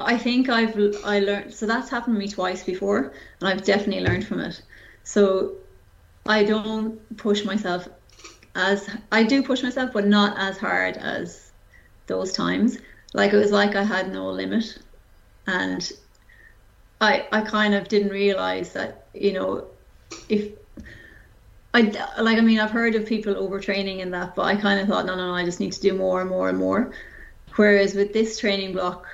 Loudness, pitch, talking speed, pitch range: -23 LUFS, 205 Hz, 180 wpm, 185-220 Hz